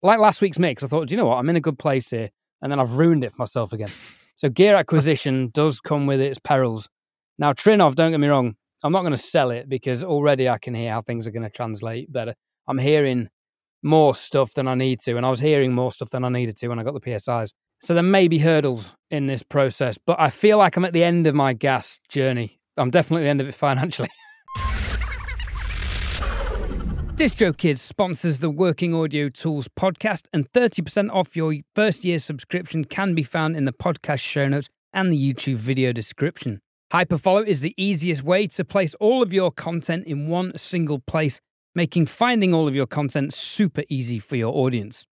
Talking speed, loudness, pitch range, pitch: 215 wpm, -22 LUFS, 125-170 Hz, 145 Hz